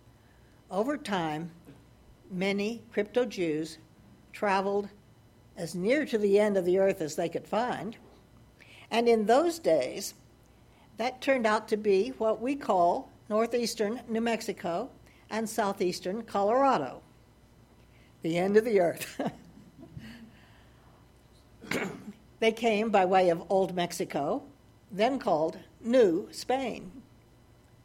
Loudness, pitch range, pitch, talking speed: -29 LUFS, 165-225 Hz, 200 Hz, 110 wpm